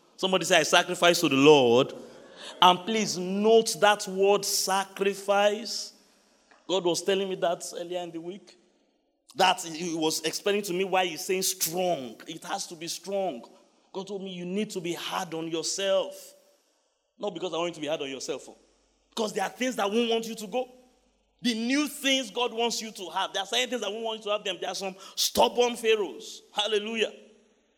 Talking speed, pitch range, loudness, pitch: 200 wpm, 180-230 Hz, -26 LUFS, 200 Hz